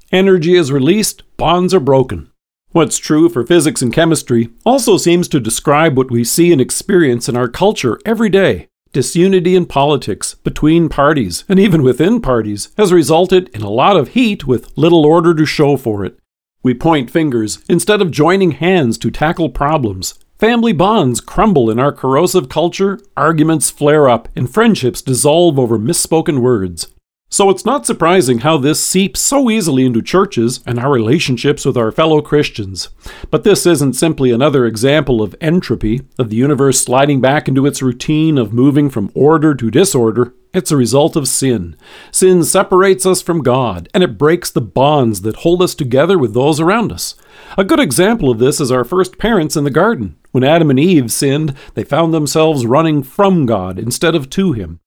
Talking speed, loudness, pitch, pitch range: 180 wpm, -12 LUFS, 150 Hz, 125-175 Hz